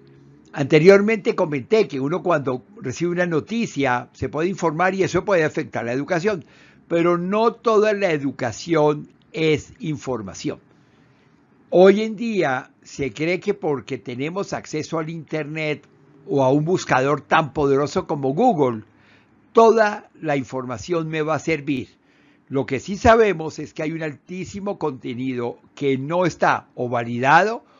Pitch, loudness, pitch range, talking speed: 155 Hz, -21 LUFS, 130-180 Hz, 140 wpm